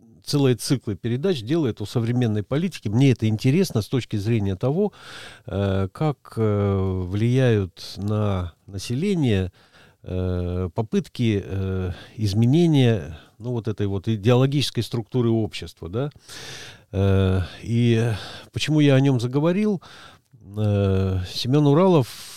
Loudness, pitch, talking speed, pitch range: -22 LUFS, 115 Hz, 95 wpm, 100-130 Hz